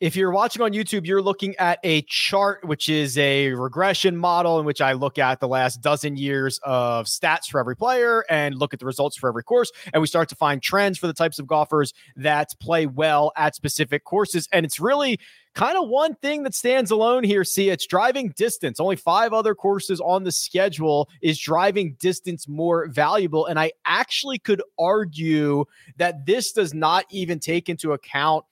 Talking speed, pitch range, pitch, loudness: 200 wpm, 145-195 Hz, 165 Hz, -21 LUFS